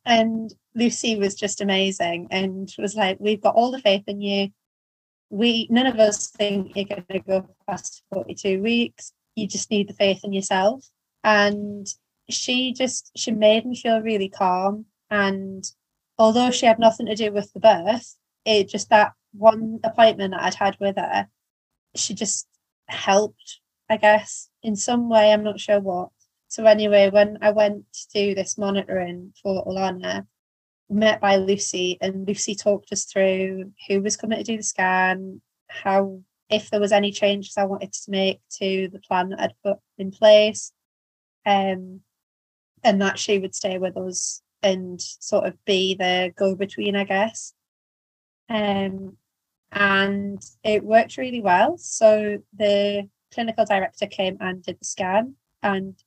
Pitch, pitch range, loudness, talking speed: 200 Hz, 190-215 Hz, -21 LUFS, 160 wpm